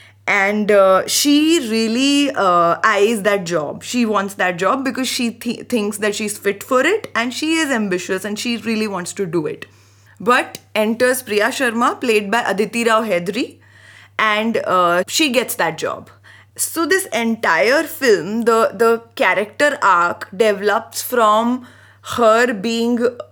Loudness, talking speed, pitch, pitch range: -17 LUFS, 150 wpm, 225 Hz, 200-250 Hz